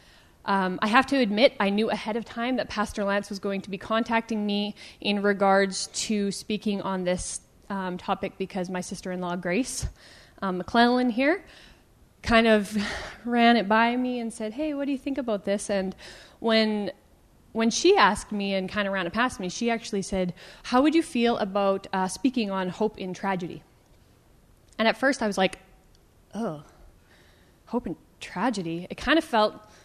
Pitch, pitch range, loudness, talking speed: 210 Hz, 195-235 Hz, -26 LUFS, 185 wpm